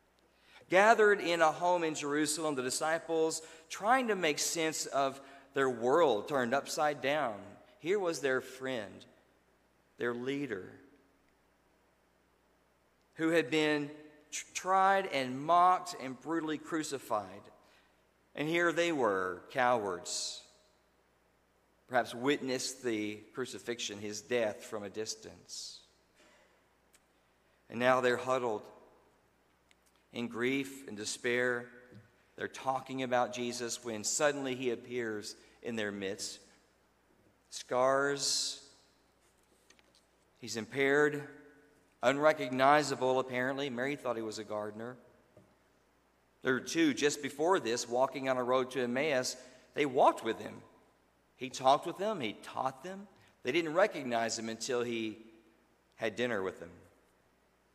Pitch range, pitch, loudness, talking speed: 120-150 Hz, 130 Hz, -33 LUFS, 115 wpm